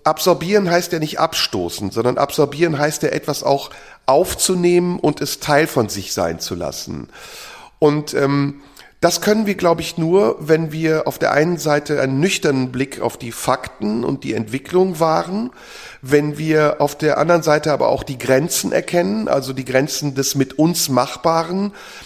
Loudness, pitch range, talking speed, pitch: -18 LUFS, 140-175 Hz, 170 wpm, 150 Hz